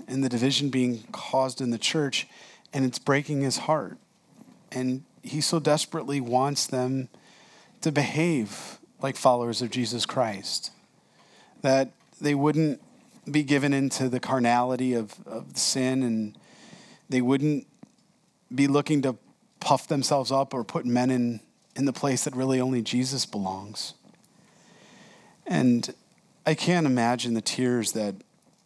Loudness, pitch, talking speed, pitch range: -26 LUFS, 135 Hz, 135 wpm, 125-155 Hz